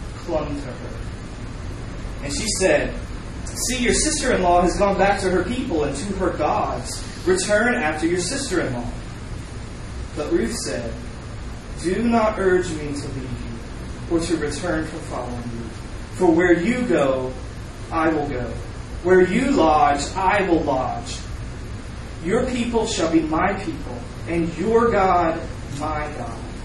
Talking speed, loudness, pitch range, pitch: 150 wpm, -21 LUFS, 120-185 Hz, 160 Hz